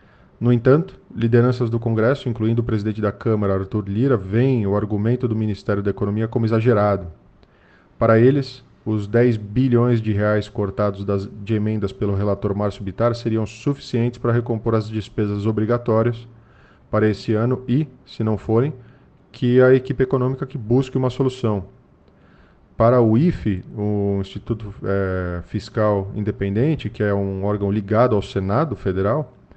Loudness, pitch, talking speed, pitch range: -20 LUFS, 110 Hz, 150 wpm, 105-120 Hz